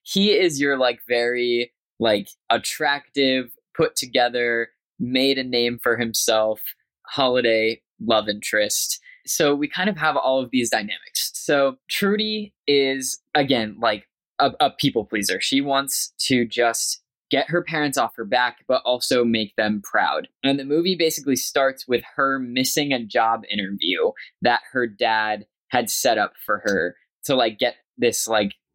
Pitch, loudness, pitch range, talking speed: 130 Hz, -21 LUFS, 115-145 Hz, 155 wpm